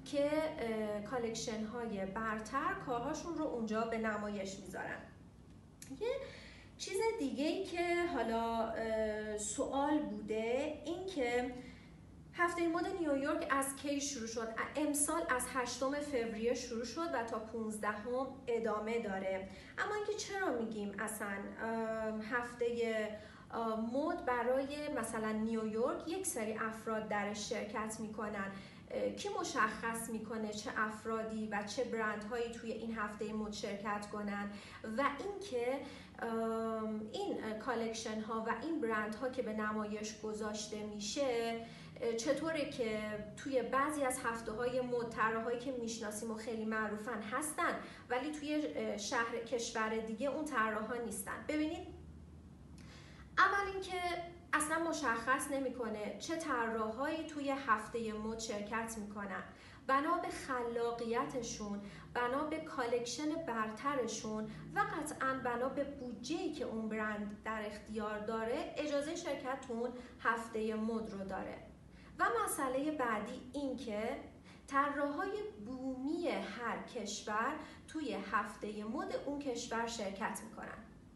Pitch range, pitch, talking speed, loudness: 220-275 Hz, 235 Hz, 120 wpm, -39 LUFS